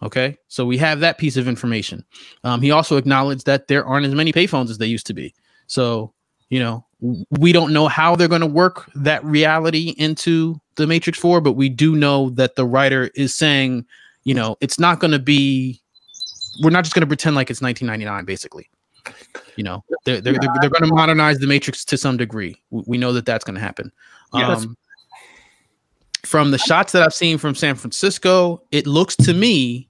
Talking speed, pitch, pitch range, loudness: 200 wpm, 140 Hz, 125-160 Hz, -17 LUFS